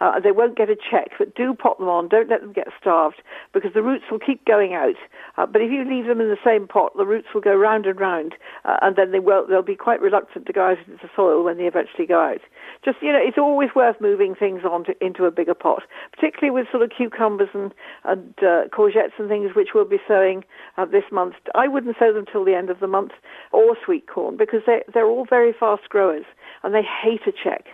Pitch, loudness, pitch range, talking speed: 220 Hz, -20 LUFS, 195-270 Hz, 255 wpm